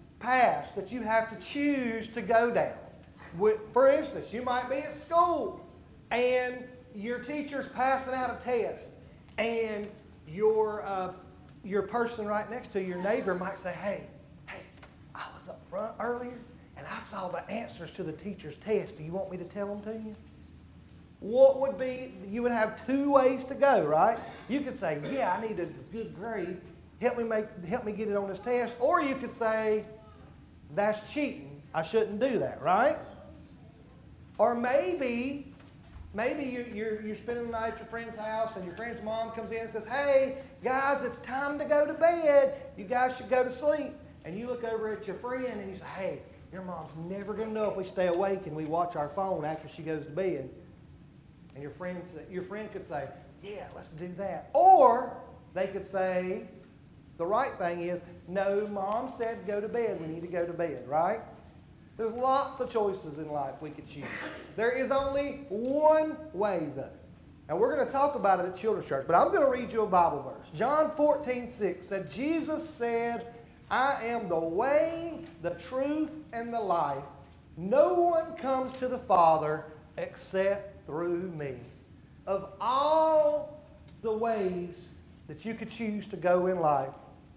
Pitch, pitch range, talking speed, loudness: 220 Hz, 185-255 Hz, 185 wpm, -30 LUFS